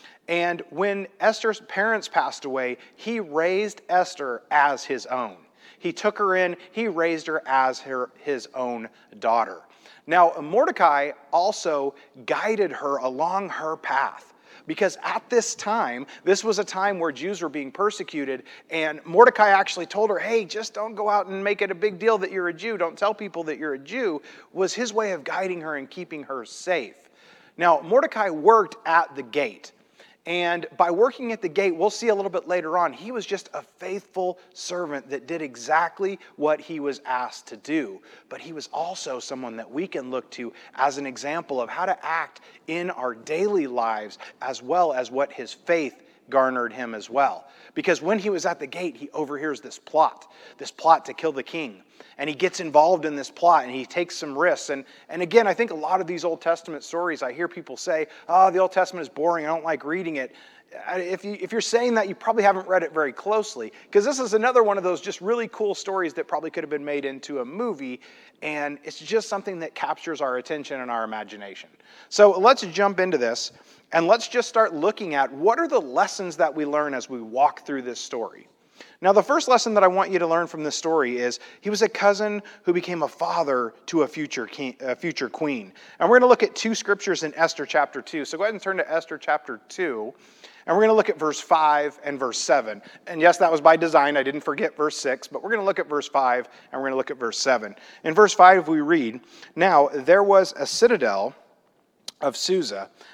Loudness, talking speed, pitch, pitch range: -23 LUFS, 215 wpm, 175 Hz, 150-205 Hz